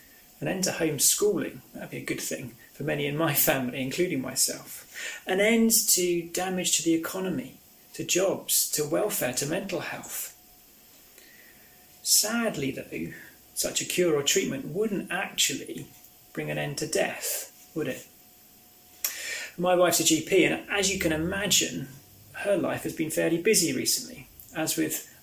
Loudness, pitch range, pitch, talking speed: -26 LUFS, 145-195 Hz, 170 Hz, 150 wpm